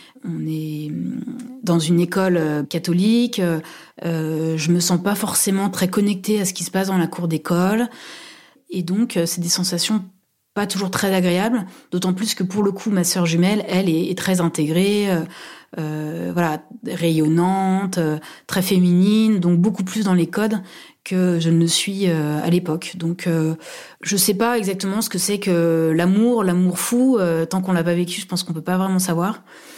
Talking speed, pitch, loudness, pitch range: 175 wpm, 180 Hz, -20 LUFS, 170-200 Hz